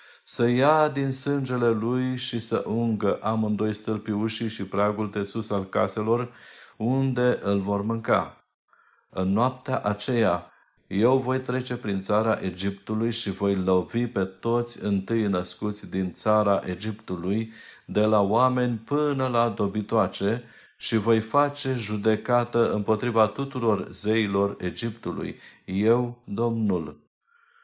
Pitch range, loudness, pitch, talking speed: 100-120 Hz, -25 LUFS, 110 Hz, 120 wpm